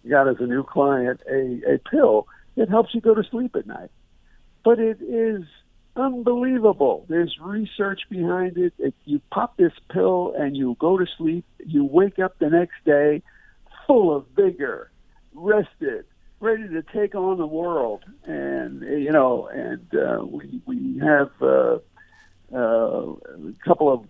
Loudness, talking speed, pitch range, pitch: -22 LUFS, 160 wpm, 150-250 Hz, 195 Hz